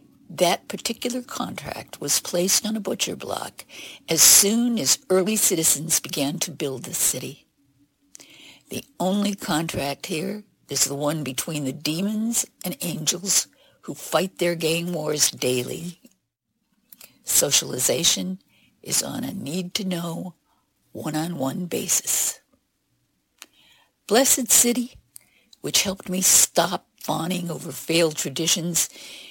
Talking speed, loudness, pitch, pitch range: 110 wpm, -21 LUFS, 175 Hz, 150-205 Hz